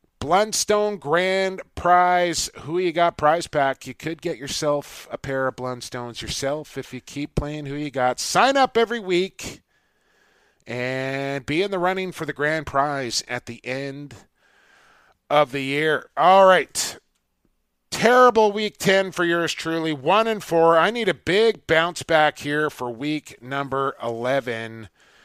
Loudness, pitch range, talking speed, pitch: -21 LUFS, 135-175 Hz, 155 wpm, 150 Hz